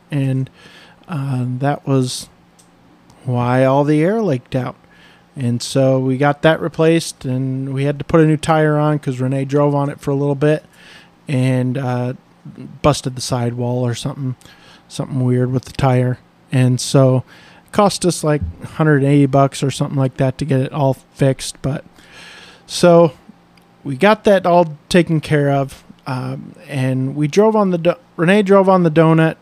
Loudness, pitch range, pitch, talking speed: -16 LUFS, 130-160 Hz, 140 Hz, 175 wpm